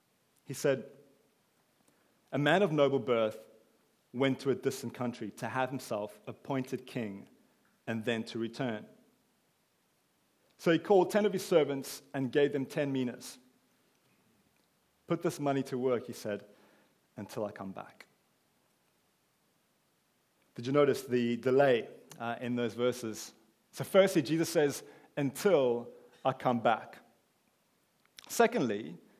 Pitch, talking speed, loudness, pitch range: 130 Hz, 125 wpm, -32 LUFS, 120-145 Hz